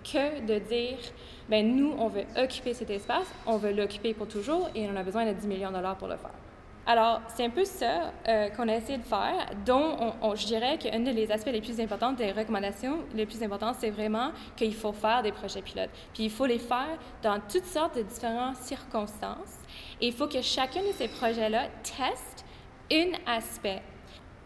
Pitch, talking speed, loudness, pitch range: 230 Hz, 205 wpm, -30 LUFS, 215-255 Hz